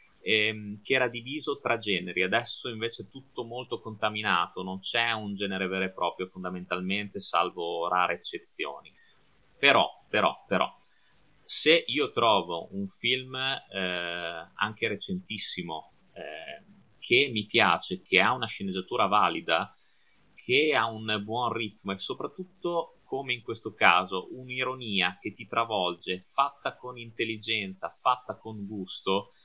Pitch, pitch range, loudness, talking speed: 110 Hz, 95-125 Hz, -28 LUFS, 130 wpm